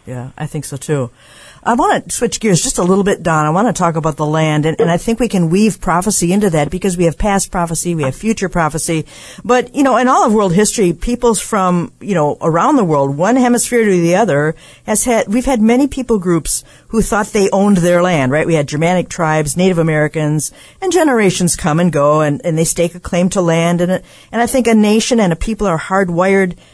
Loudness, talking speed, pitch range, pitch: -14 LUFS, 235 wpm, 160-215 Hz, 180 Hz